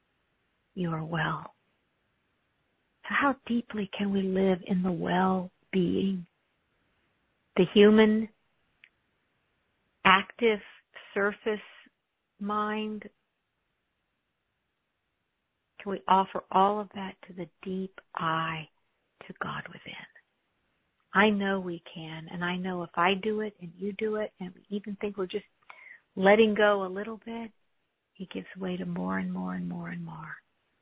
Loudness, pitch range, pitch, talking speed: -28 LUFS, 160-210 Hz, 190 Hz, 130 wpm